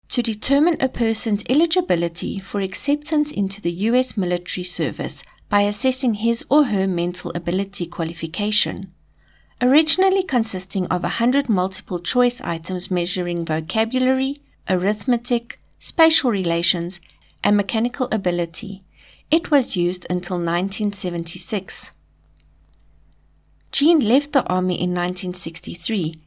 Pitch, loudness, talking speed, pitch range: 195 Hz, -21 LUFS, 105 wpm, 175-245 Hz